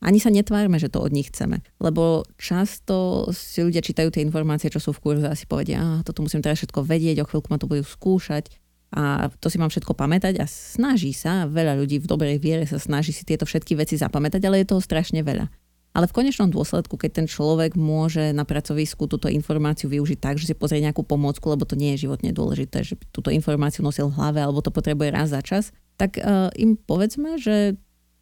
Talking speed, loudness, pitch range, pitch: 225 wpm, -23 LUFS, 150-175 Hz, 155 Hz